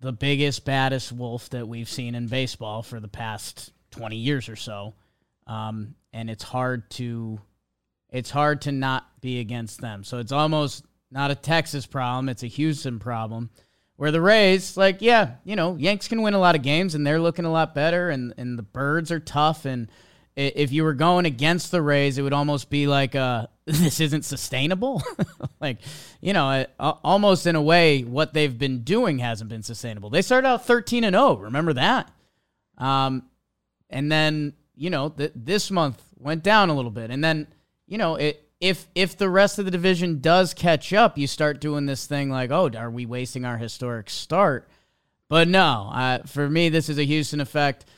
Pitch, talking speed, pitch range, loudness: 145 Hz, 195 wpm, 125-165 Hz, -23 LUFS